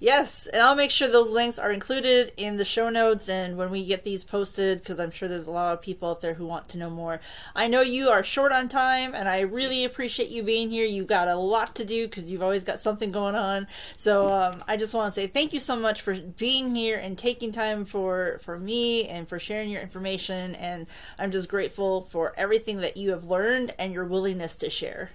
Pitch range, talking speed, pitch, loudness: 185-230 Hz, 240 wpm, 200 Hz, -26 LUFS